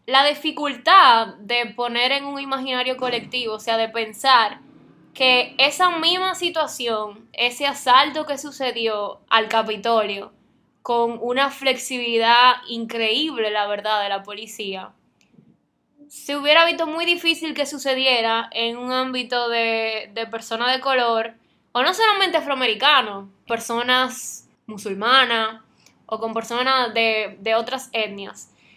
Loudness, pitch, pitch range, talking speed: -20 LUFS, 245 Hz, 225-275 Hz, 125 wpm